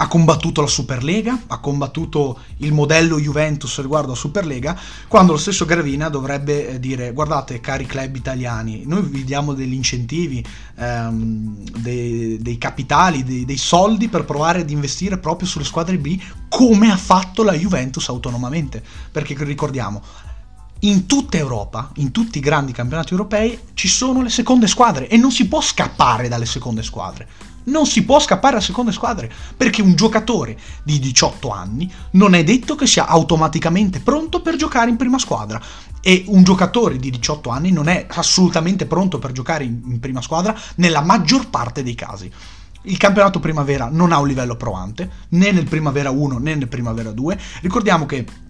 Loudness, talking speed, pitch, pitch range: -17 LUFS, 165 wpm, 155 Hz, 130-190 Hz